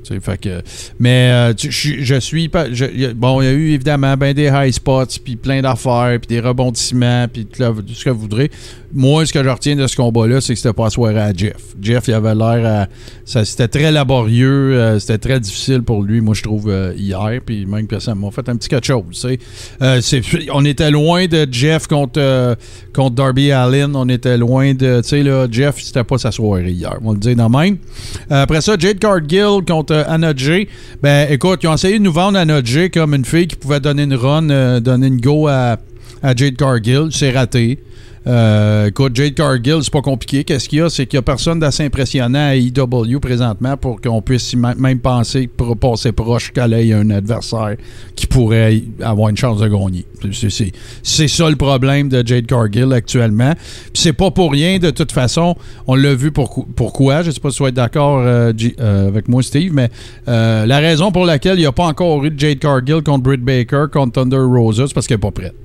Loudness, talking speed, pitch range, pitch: -14 LUFS, 225 wpm, 115-145 Hz, 130 Hz